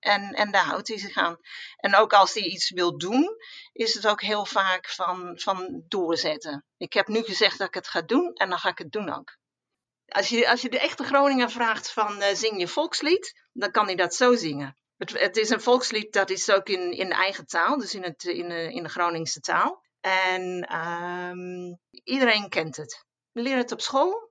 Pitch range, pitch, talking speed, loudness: 175-240 Hz, 200 Hz, 220 wpm, -25 LUFS